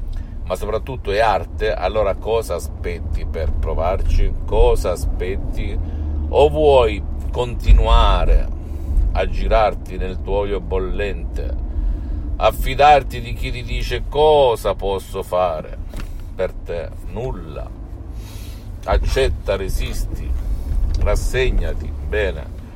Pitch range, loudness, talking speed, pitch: 75-95 Hz, -20 LUFS, 90 wpm, 85 Hz